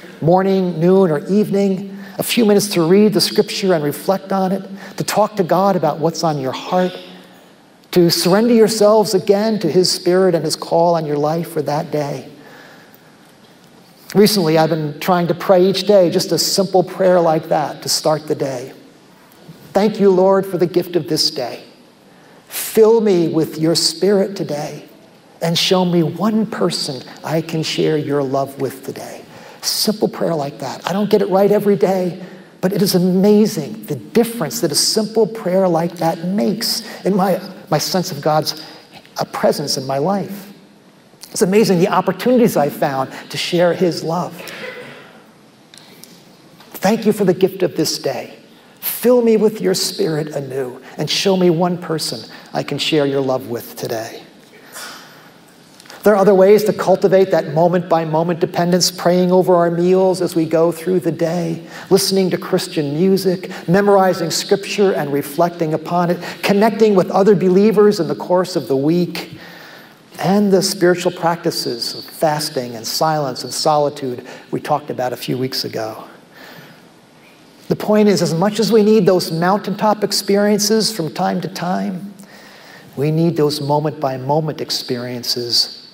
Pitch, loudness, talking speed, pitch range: 180 Hz, -16 LUFS, 165 wpm, 160-195 Hz